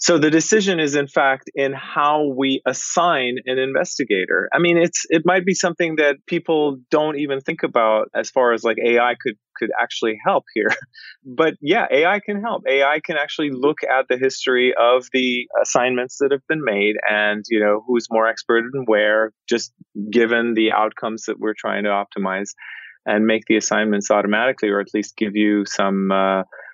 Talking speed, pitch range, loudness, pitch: 185 wpm, 110-150 Hz, -19 LUFS, 125 Hz